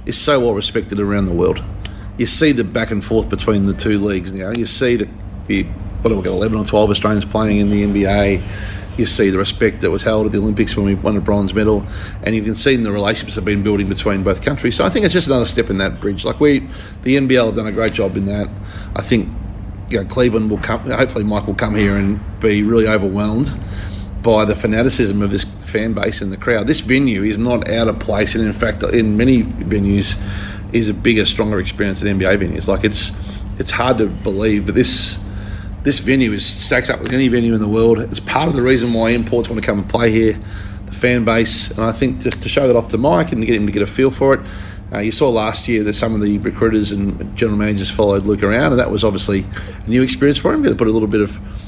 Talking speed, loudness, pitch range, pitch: 250 wpm, -16 LUFS, 100-115 Hz, 105 Hz